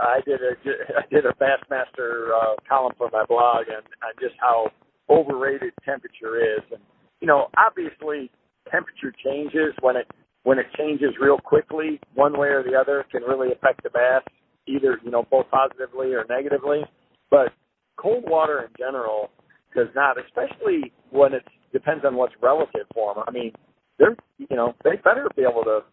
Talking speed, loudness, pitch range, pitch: 175 wpm, -22 LUFS, 125-155 Hz, 140 Hz